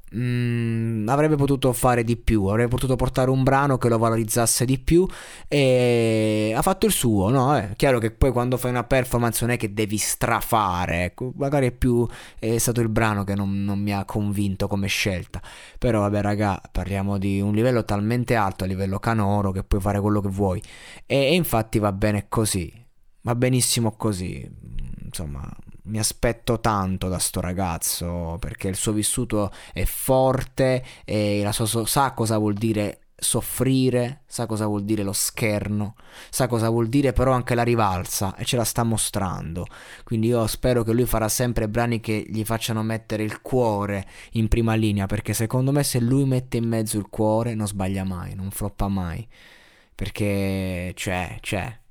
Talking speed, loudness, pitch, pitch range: 180 wpm, -23 LUFS, 110 Hz, 100-120 Hz